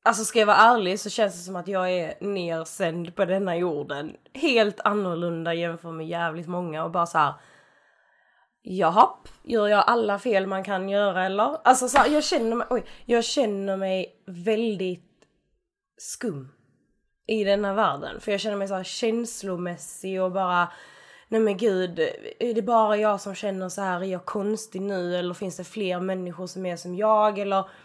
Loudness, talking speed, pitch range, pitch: -25 LUFS, 180 wpm, 180-220 Hz, 195 Hz